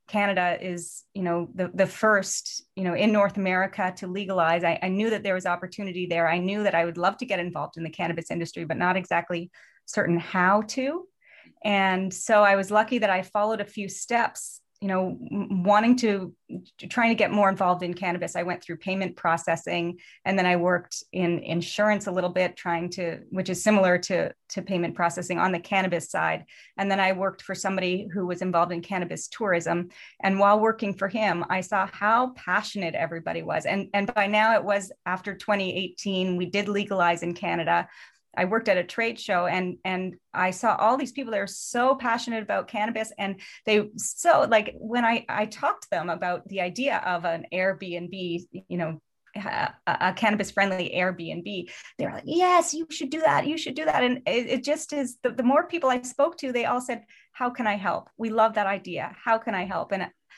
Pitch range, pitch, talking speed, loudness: 180-220 Hz, 195 Hz, 205 wpm, -26 LUFS